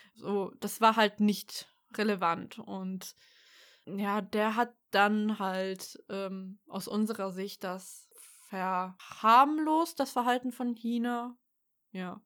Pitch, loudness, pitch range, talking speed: 210 Hz, -30 LUFS, 195-245 Hz, 115 wpm